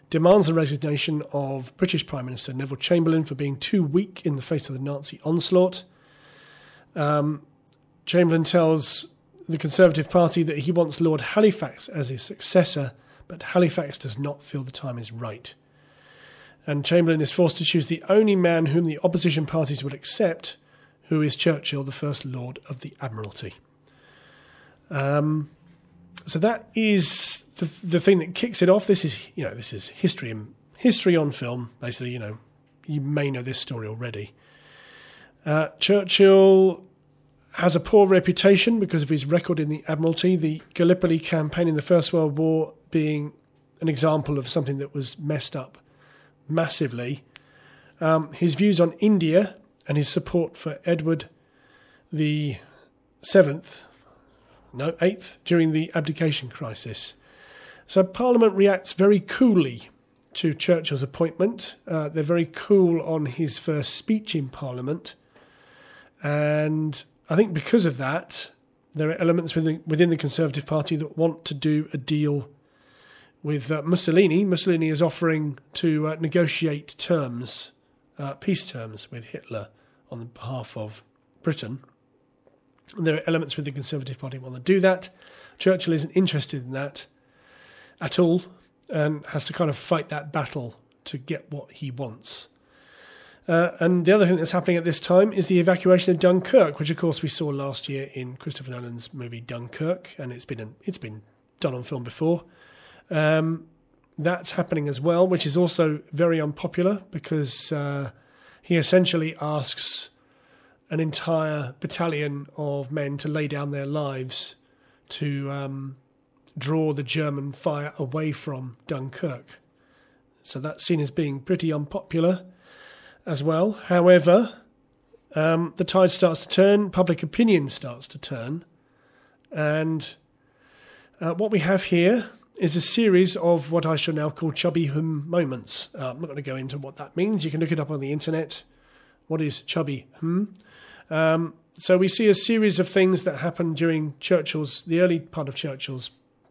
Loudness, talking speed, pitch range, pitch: -23 LUFS, 160 wpm, 140-175 Hz, 155 Hz